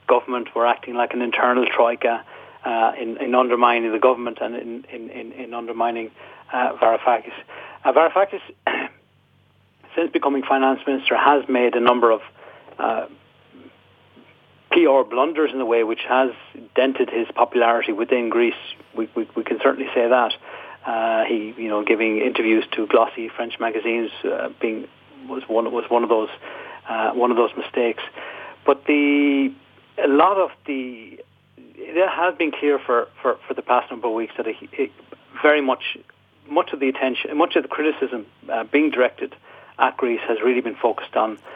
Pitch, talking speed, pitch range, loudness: 125 Hz, 165 wpm, 115-145 Hz, -20 LUFS